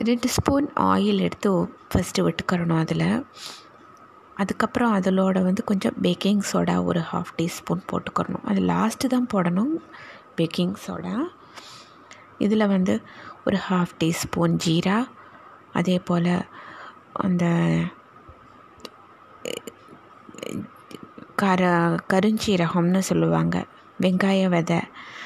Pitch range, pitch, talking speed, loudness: 170-220 Hz, 190 Hz, 90 wpm, -23 LUFS